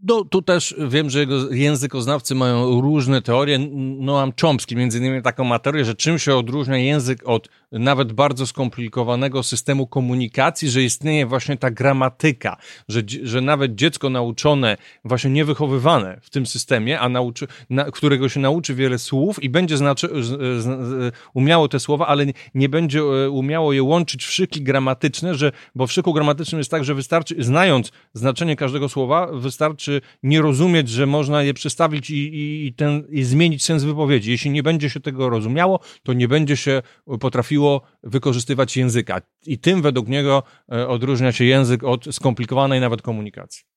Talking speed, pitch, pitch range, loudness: 165 wpm, 135 Hz, 130-150 Hz, -19 LUFS